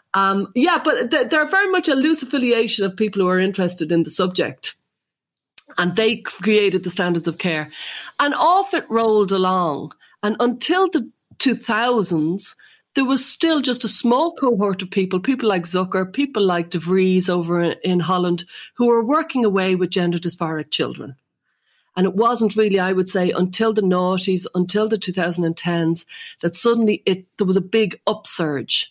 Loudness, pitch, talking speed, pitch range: -19 LUFS, 195 Hz, 170 wpm, 180-240 Hz